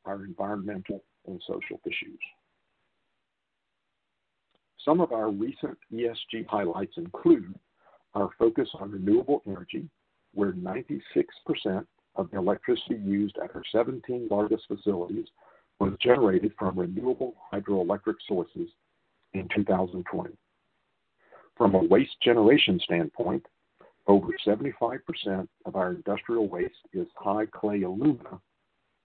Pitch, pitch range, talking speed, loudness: 105 Hz, 100-165 Hz, 105 wpm, -28 LUFS